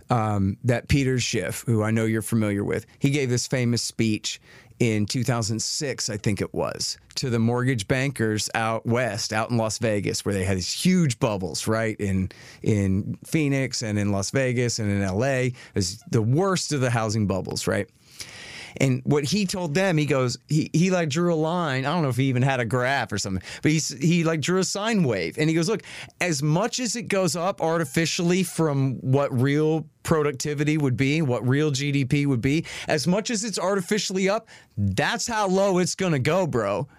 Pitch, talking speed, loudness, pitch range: 135 Hz, 200 wpm, -24 LUFS, 115-165 Hz